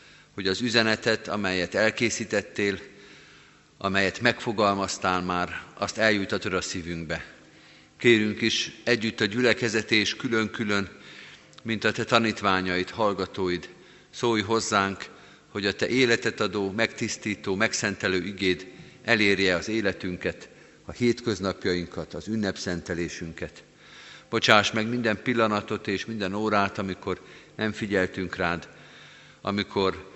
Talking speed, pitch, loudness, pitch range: 105 wpm, 100 Hz, -26 LUFS, 95-110 Hz